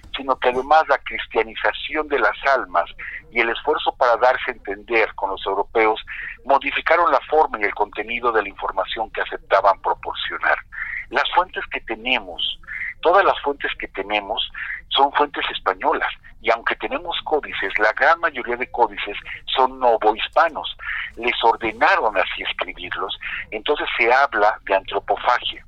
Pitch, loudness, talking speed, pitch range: 125 Hz, -20 LUFS, 145 wpm, 110-140 Hz